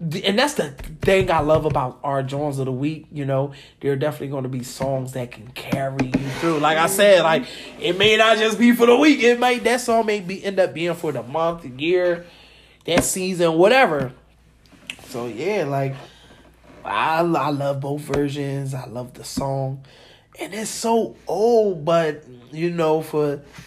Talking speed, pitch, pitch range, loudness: 190 wpm, 155 Hz, 135-190 Hz, -20 LUFS